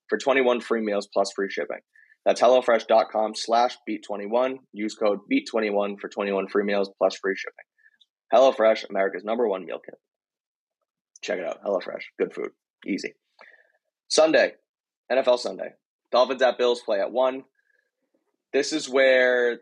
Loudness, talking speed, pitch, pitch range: -24 LUFS, 140 wpm, 120 Hz, 105-130 Hz